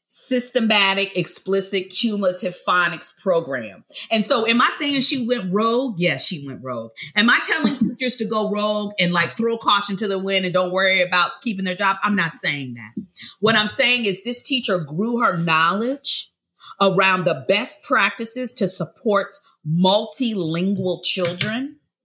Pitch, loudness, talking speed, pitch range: 200 Hz, -19 LUFS, 160 wpm, 180-235 Hz